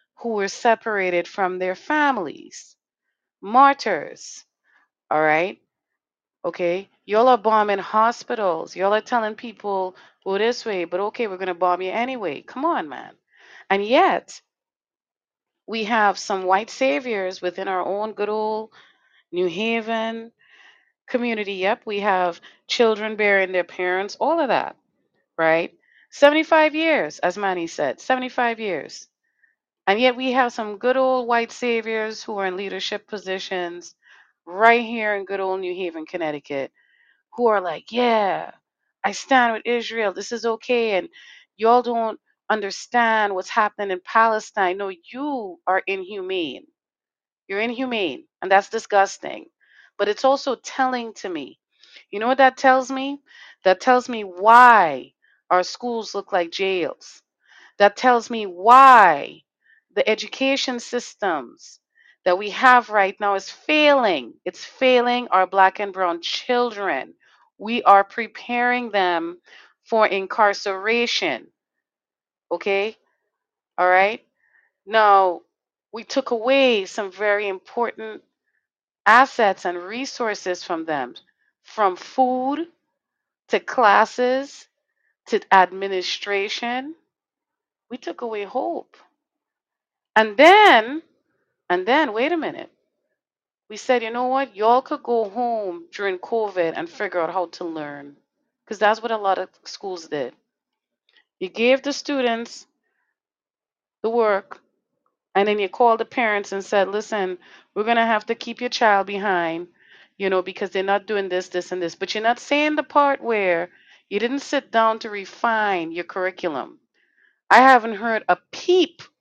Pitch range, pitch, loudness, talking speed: 195-250 Hz, 220 Hz, -20 LUFS, 140 wpm